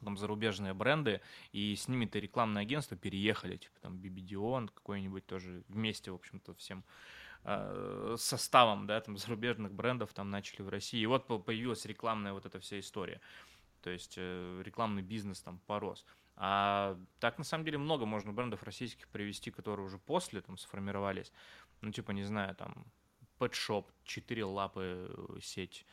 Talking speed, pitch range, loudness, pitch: 155 wpm, 95-115 Hz, -38 LUFS, 105 Hz